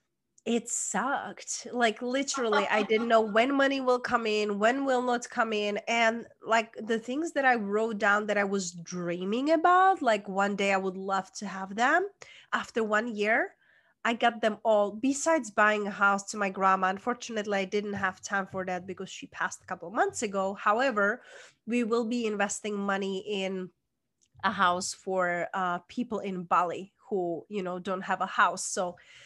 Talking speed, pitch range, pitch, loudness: 185 wpm, 195-235 Hz, 210 Hz, -28 LUFS